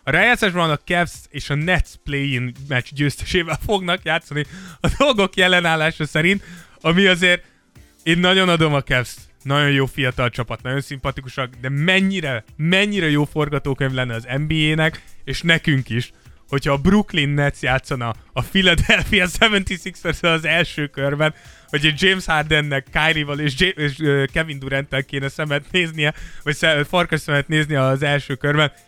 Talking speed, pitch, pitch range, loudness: 150 wpm, 150 Hz, 140-170 Hz, -19 LUFS